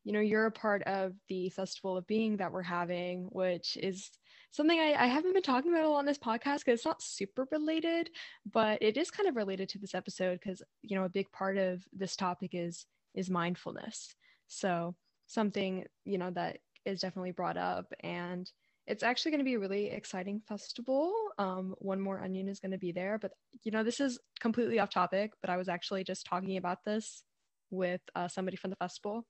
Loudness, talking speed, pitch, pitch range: -35 LUFS, 210 wpm, 195 Hz, 185-230 Hz